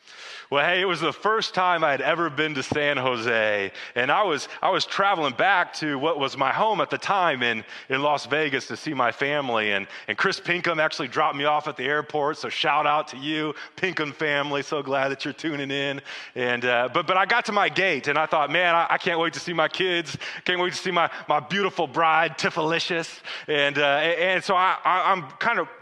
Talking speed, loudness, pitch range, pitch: 235 wpm, -23 LUFS, 140-170 Hz, 155 Hz